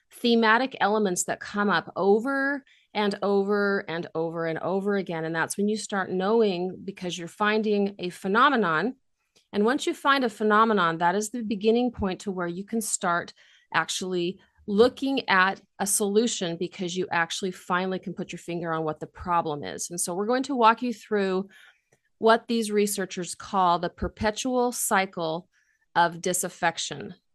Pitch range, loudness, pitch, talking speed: 175-225 Hz, -26 LUFS, 200 Hz, 165 wpm